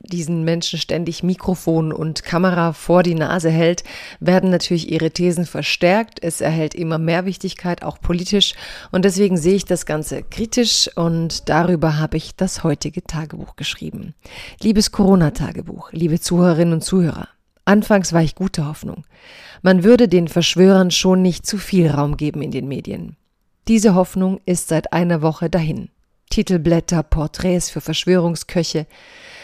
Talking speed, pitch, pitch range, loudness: 145 wpm, 175 Hz, 160-185 Hz, -17 LUFS